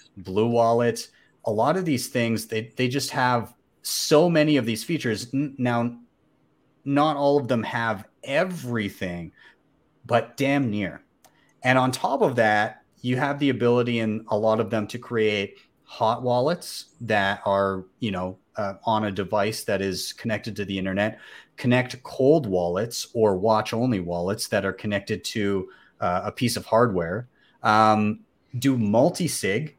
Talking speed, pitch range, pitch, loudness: 155 wpm, 105-125 Hz, 115 Hz, -24 LUFS